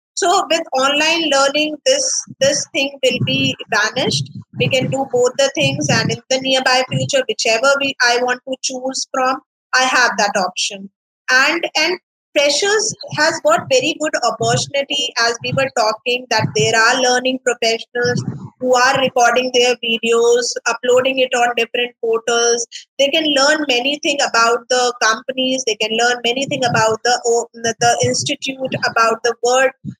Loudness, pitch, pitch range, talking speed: -15 LUFS, 255 Hz, 235-275 Hz, 160 wpm